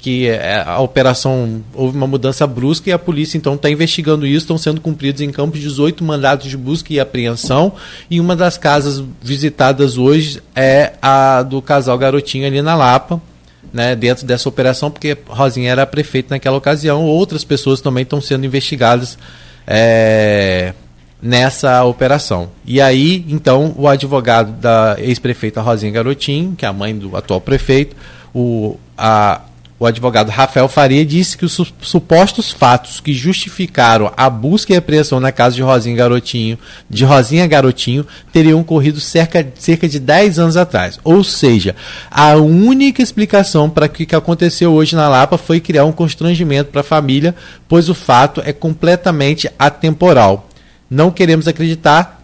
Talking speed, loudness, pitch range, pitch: 155 wpm, -12 LUFS, 125-160 Hz, 140 Hz